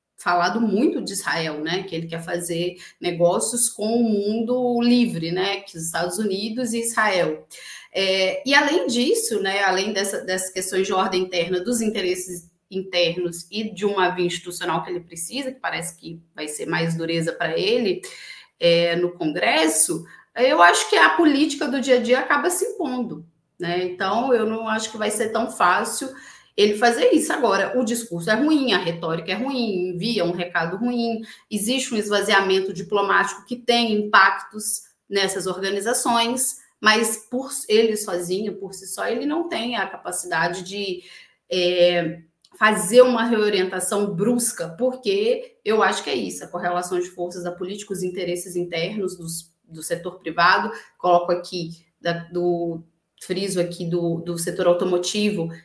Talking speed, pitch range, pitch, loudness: 160 wpm, 175-230 Hz, 195 Hz, -21 LUFS